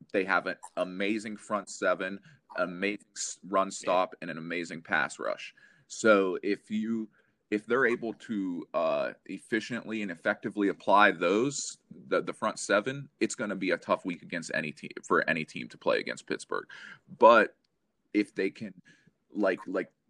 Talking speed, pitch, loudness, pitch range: 160 wpm, 105 Hz, -30 LUFS, 95-110 Hz